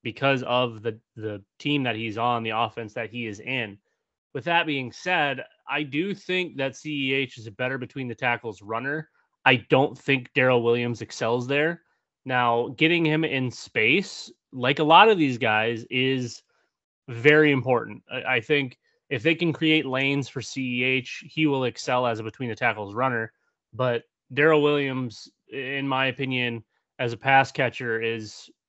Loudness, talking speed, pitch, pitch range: -24 LUFS, 165 wpm, 130 Hz, 115-140 Hz